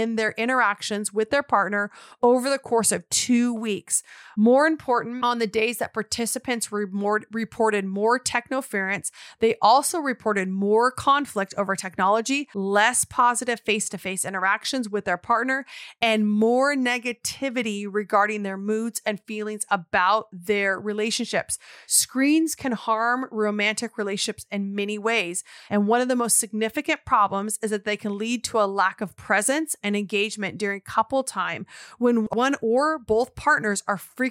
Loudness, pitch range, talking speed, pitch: -23 LUFS, 205-245 Hz, 150 wpm, 220 Hz